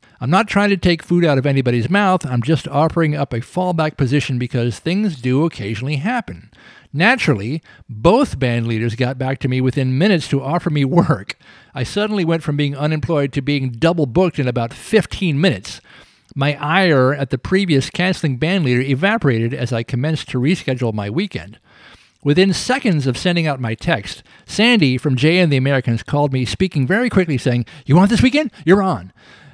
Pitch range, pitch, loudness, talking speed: 130-175 Hz, 145 Hz, -17 LUFS, 185 wpm